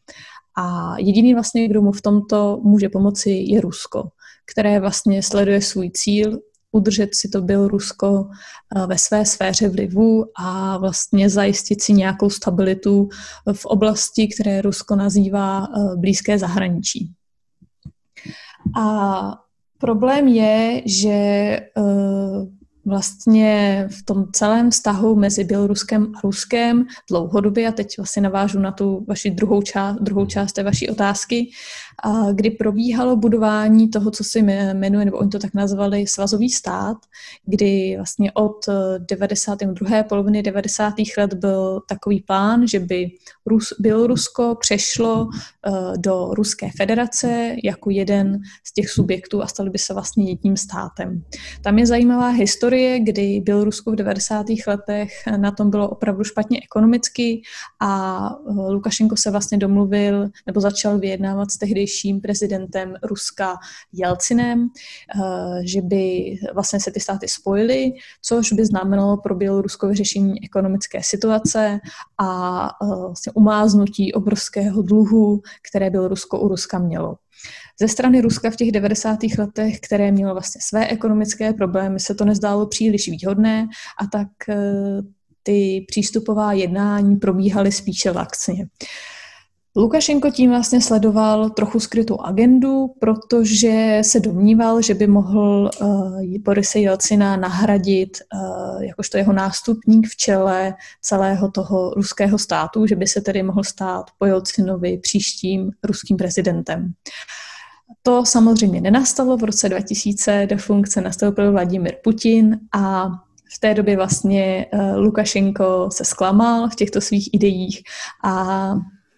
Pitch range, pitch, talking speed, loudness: 195-220 Hz, 205 Hz, 130 wpm, -18 LUFS